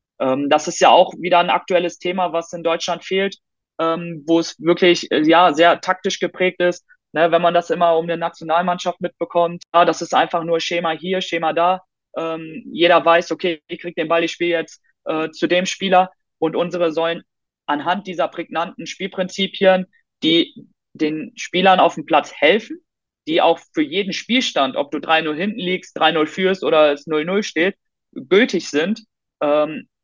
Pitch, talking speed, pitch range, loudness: 175 Hz, 160 wpm, 165-185 Hz, -18 LUFS